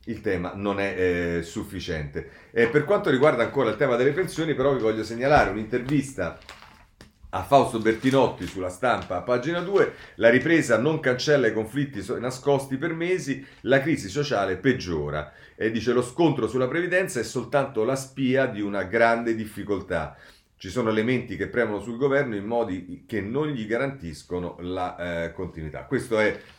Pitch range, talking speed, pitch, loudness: 95-135 Hz, 170 wpm, 115 Hz, -25 LUFS